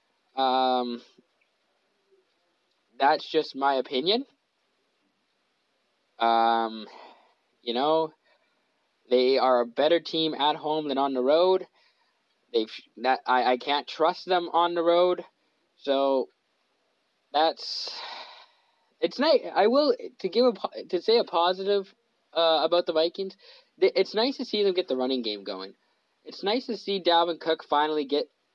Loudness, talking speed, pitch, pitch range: -25 LUFS, 135 wpm, 165 Hz, 135-200 Hz